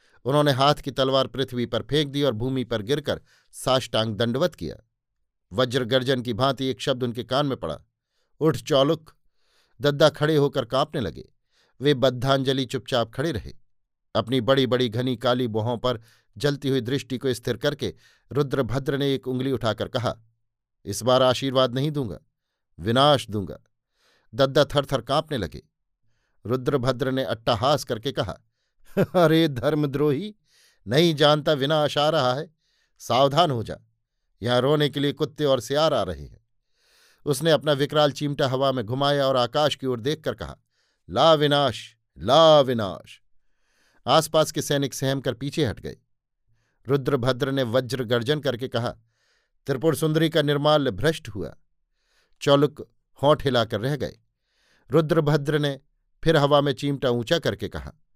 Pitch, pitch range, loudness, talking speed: 135 Hz, 120-145 Hz, -23 LUFS, 150 wpm